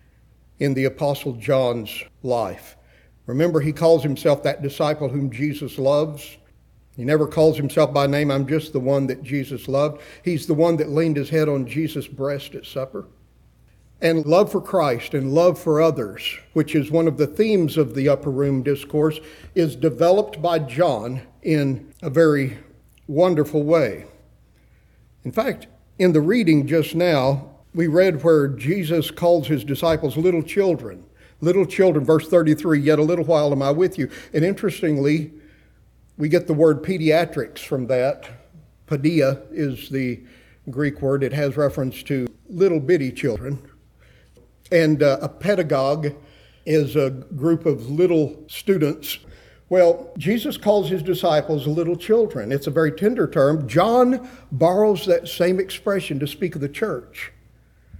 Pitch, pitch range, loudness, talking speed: 150 Hz, 140-170 Hz, -20 LUFS, 150 wpm